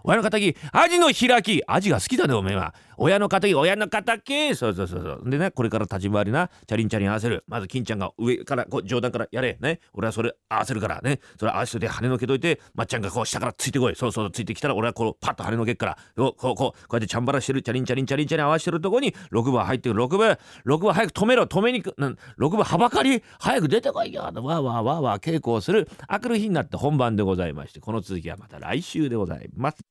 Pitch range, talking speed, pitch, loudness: 110-175 Hz, 515 characters per minute, 125 Hz, -24 LUFS